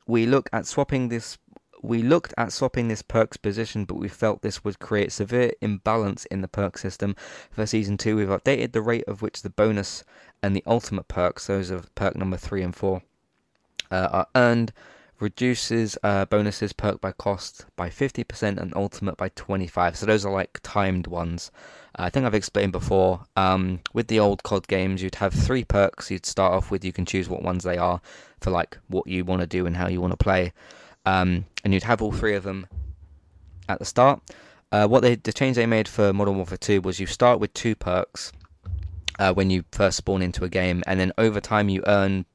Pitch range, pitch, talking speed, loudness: 90-110 Hz, 100 Hz, 210 wpm, -24 LUFS